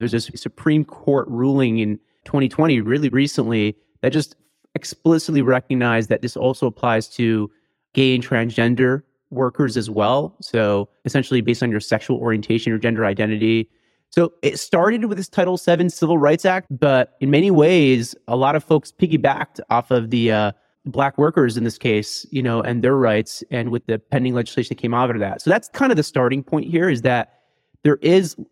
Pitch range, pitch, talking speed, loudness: 115-145 Hz, 130 Hz, 185 wpm, -19 LUFS